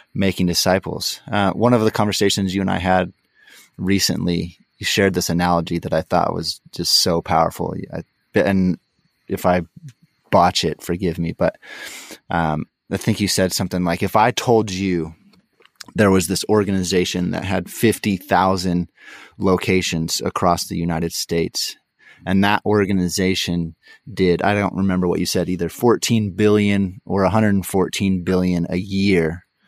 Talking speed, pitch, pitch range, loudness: 150 wpm, 95 Hz, 90-100 Hz, -19 LUFS